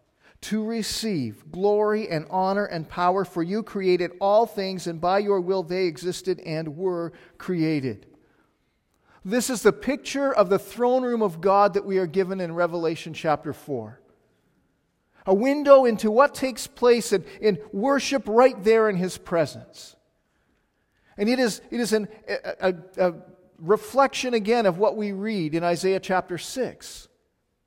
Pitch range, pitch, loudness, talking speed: 175-220 Hz, 195 Hz, -24 LUFS, 155 wpm